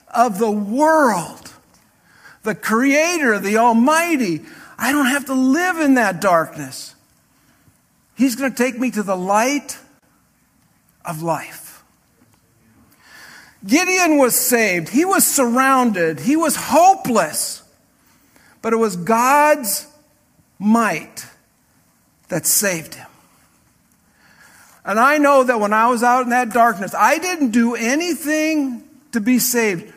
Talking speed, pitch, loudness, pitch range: 120 wpm, 250 Hz, -16 LUFS, 225-285 Hz